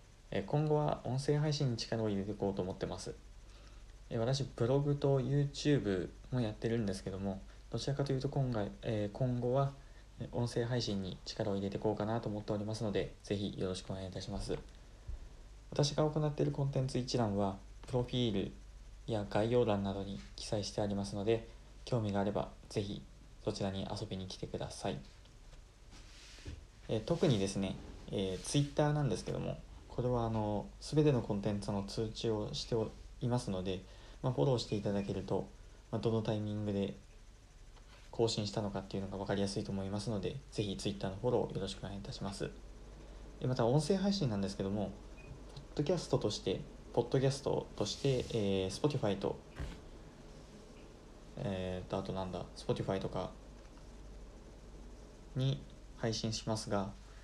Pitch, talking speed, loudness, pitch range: 110 Hz, 355 characters per minute, -37 LUFS, 100-125 Hz